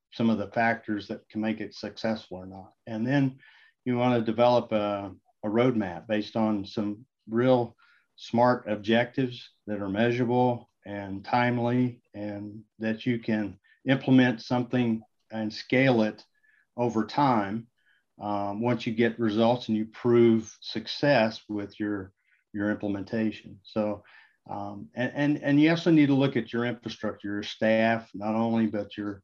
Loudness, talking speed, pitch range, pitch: -27 LUFS, 150 wpm, 105-120 Hz, 110 Hz